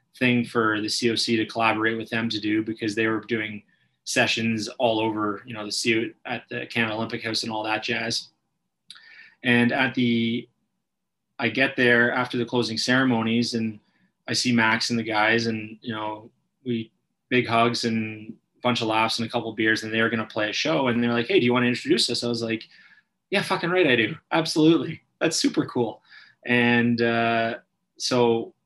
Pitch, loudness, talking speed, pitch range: 115 Hz, -23 LUFS, 205 wpm, 110-120 Hz